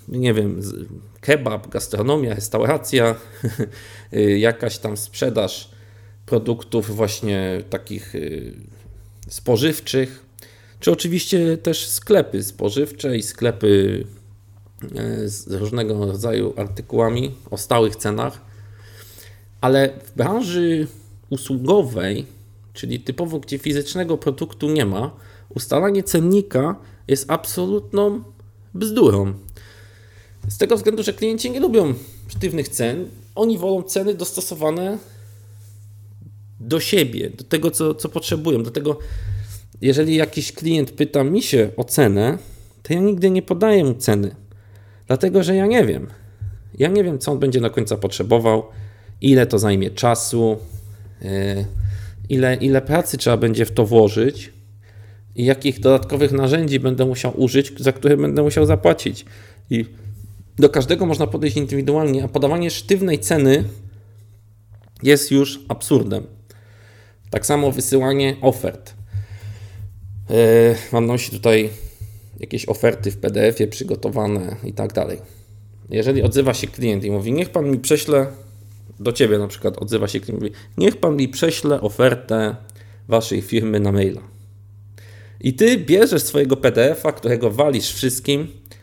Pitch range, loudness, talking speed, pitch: 105-140 Hz, -19 LUFS, 120 wpm, 115 Hz